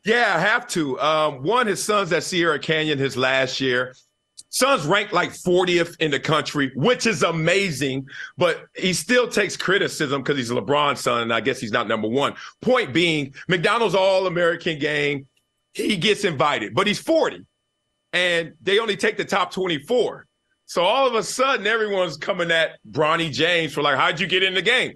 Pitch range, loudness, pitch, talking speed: 145-195 Hz, -21 LUFS, 170 Hz, 185 wpm